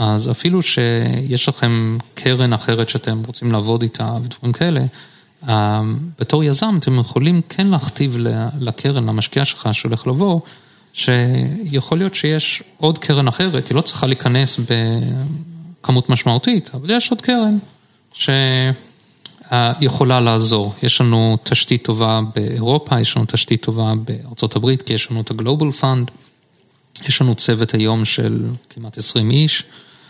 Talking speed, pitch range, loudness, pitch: 130 wpm, 115-145 Hz, -16 LUFS, 125 Hz